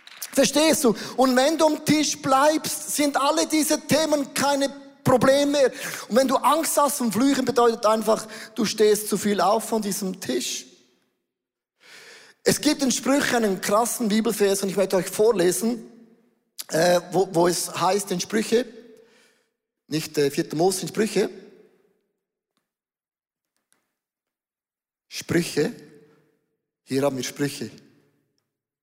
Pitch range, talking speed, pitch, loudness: 175-265 Hz, 125 wpm, 220 Hz, -22 LUFS